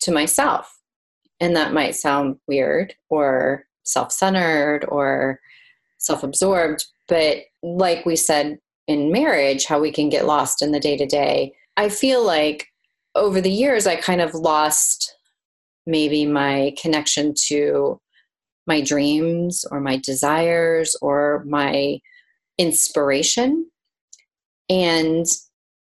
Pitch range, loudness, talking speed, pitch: 145-170 Hz, -19 LUFS, 115 wpm, 150 Hz